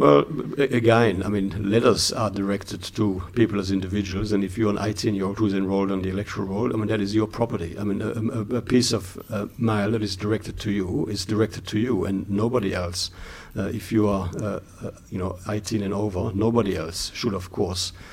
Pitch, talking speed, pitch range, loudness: 105 Hz, 210 wpm, 95-110 Hz, -24 LUFS